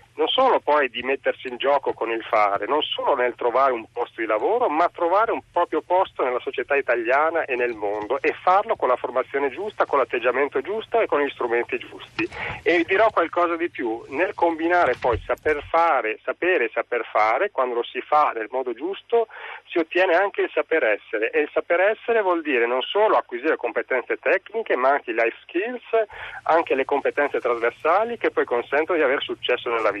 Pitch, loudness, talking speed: 180 Hz, -22 LUFS, 200 wpm